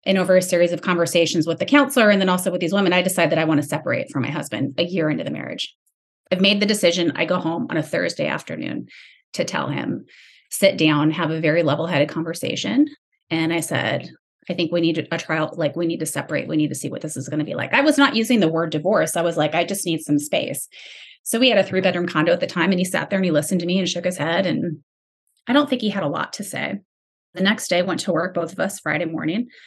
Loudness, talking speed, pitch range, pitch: -20 LUFS, 270 wpm, 160-190 Hz, 170 Hz